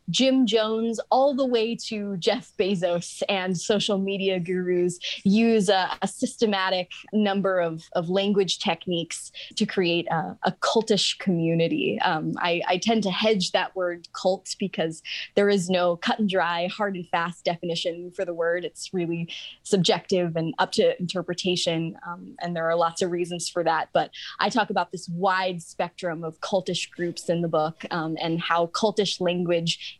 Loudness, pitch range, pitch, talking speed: -25 LUFS, 170-200 Hz, 180 Hz, 170 wpm